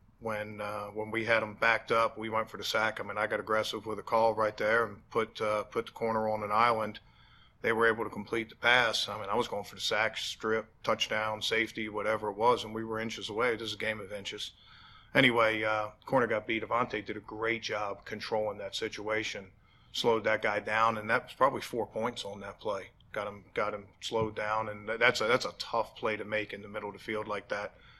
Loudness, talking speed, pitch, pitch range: -31 LUFS, 240 wpm, 110 Hz, 105-115 Hz